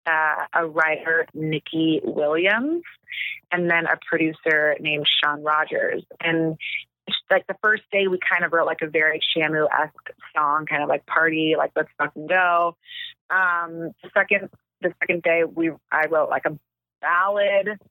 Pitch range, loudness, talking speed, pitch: 155-185 Hz, -22 LUFS, 160 wpm, 165 Hz